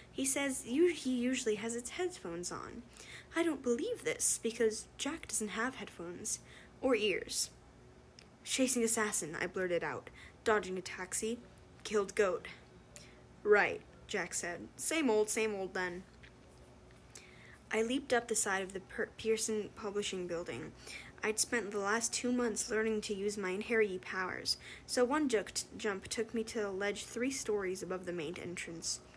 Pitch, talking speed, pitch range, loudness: 220 Hz, 155 wpm, 195-245 Hz, -35 LUFS